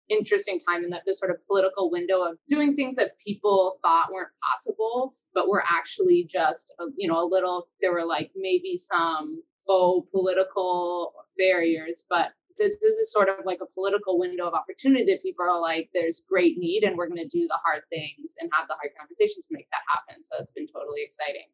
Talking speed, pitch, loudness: 210 wpm, 190 Hz, -25 LUFS